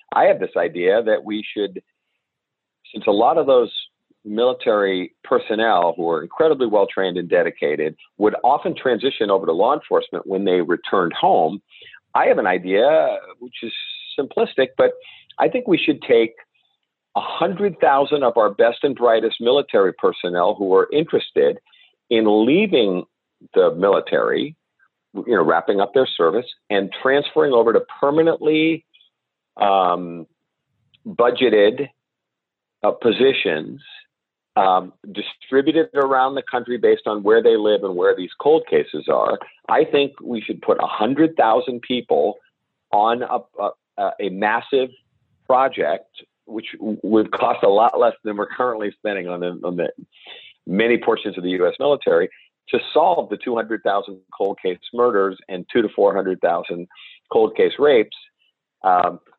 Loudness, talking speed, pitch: -19 LUFS, 145 wpm, 290 Hz